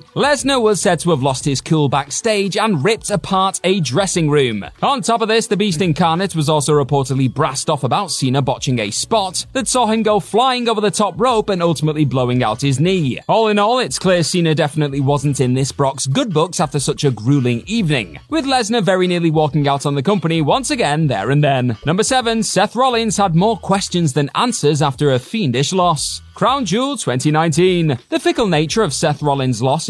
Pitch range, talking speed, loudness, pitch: 140-210 Hz, 205 wpm, -16 LUFS, 165 Hz